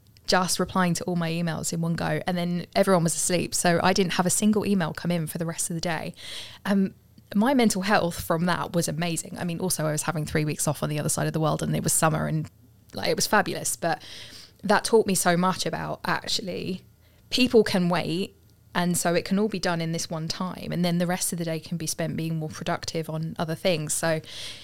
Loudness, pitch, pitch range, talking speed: -25 LUFS, 170 Hz, 160-185 Hz, 250 wpm